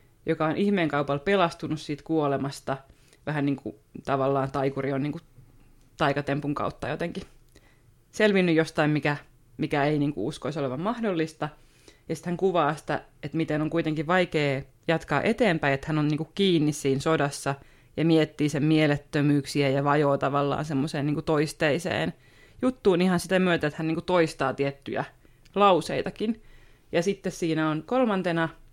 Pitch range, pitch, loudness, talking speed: 140-165 Hz, 150 Hz, -26 LUFS, 155 wpm